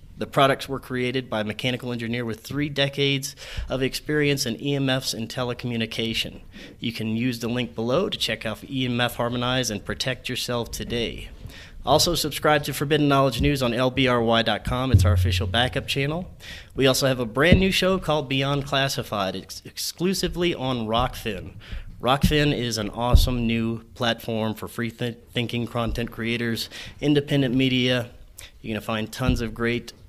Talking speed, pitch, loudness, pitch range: 160 wpm, 120 Hz, -24 LUFS, 110-135 Hz